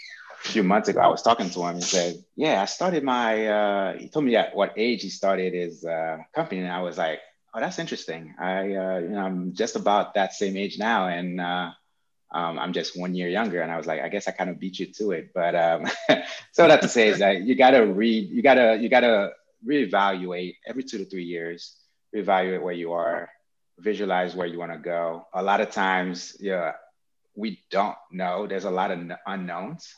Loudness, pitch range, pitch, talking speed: -24 LUFS, 85-100 Hz, 90 Hz, 230 wpm